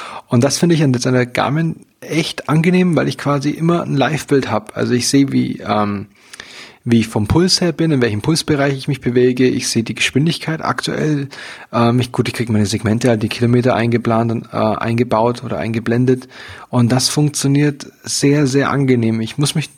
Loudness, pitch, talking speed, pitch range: -16 LUFS, 130 Hz, 190 wpm, 115-145 Hz